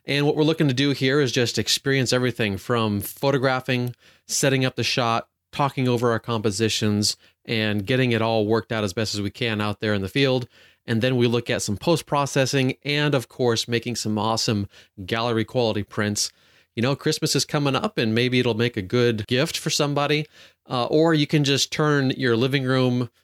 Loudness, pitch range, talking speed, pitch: -22 LUFS, 115-140 Hz, 200 wpm, 125 Hz